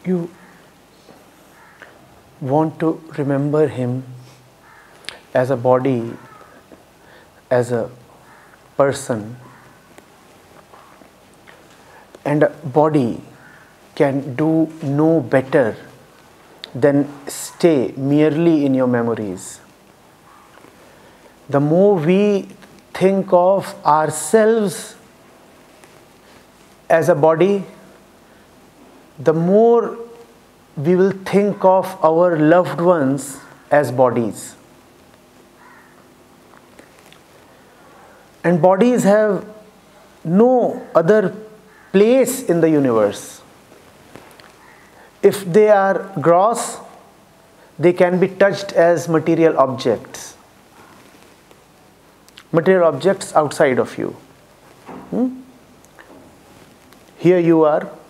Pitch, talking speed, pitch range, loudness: 165 Hz, 75 wpm, 140-195 Hz, -16 LUFS